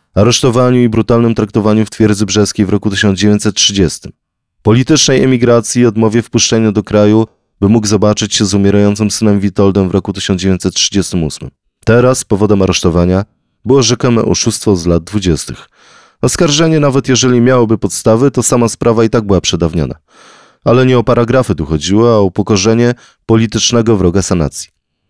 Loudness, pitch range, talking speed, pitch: -11 LUFS, 100-120 Hz, 145 wpm, 110 Hz